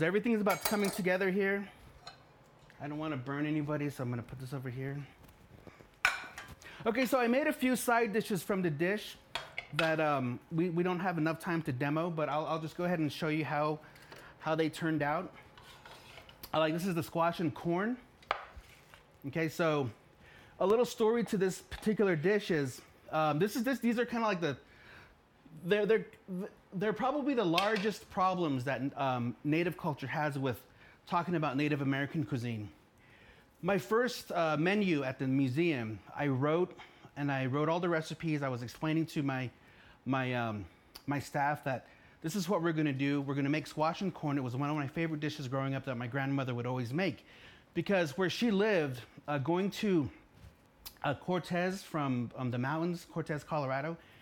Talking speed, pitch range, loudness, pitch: 190 wpm, 140-185 Hz, -34 LUFS, 155 Hz